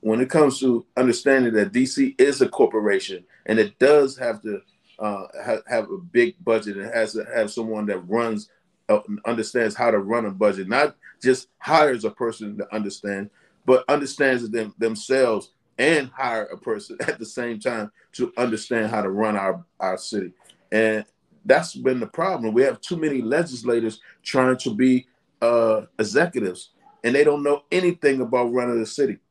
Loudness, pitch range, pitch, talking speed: -22 LUFS, 110-140 Hz, 120 Hz, 175 wpm